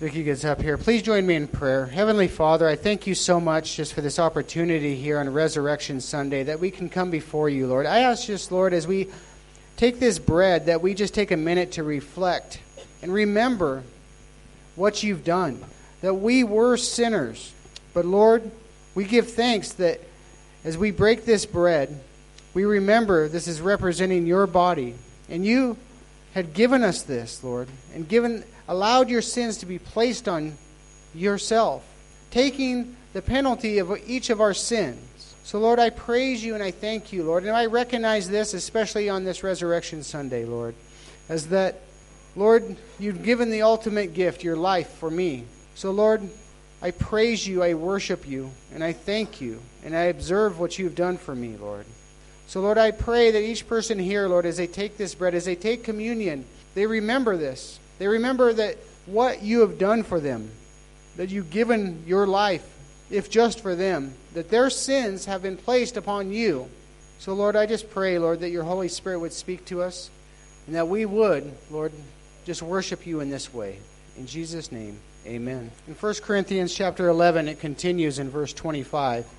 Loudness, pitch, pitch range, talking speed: -24 LUFS, 185 Hz, 155-215 Hz, 180 wpm